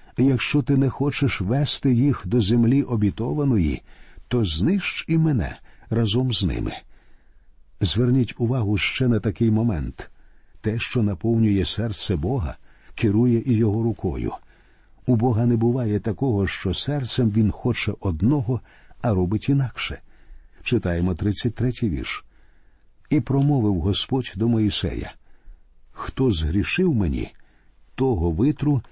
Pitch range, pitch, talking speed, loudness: 100-130 Hz, 115 Hz, 120 wpm, -22 LUFS